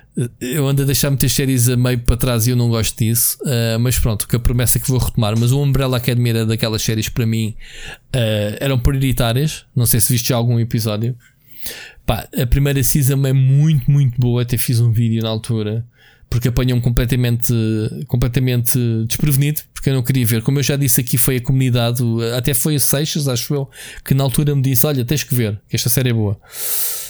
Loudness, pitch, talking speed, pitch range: -16 LUFS, 125 Hz, 215 wpm, 115-140 Hz